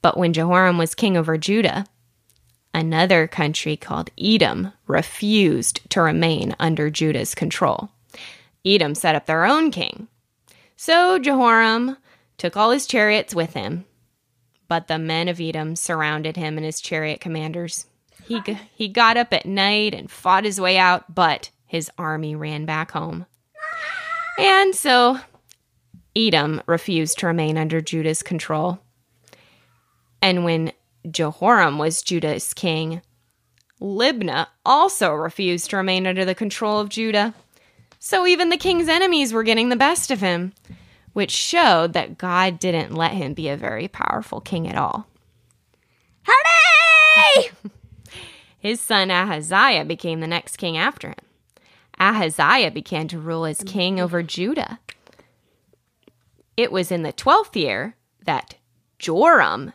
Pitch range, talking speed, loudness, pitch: 155-215 Hz, 135 wpm, -19 LUFS, 175 Hz